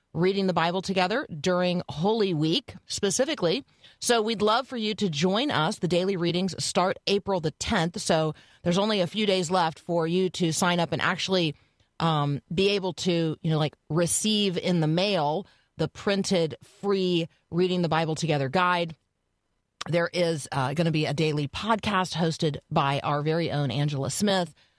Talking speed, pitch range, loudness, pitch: 175 wpm, 155-190 Hz, -26 LUFS, 170 Hz